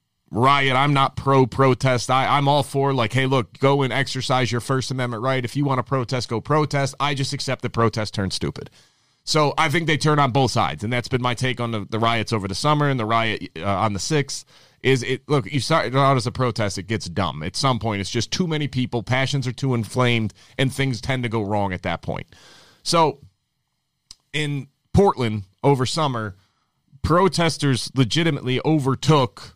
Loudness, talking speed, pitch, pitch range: -21 LUFS, 205 wpm, 130 Hz, 115-140 Hz